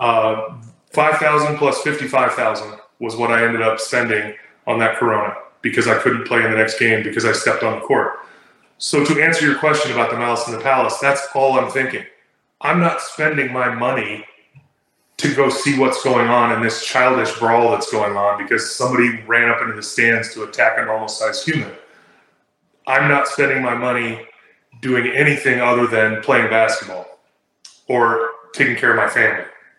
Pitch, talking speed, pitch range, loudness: 120 Hz, 185 wpm, 115-135 Hz, -17 LUFS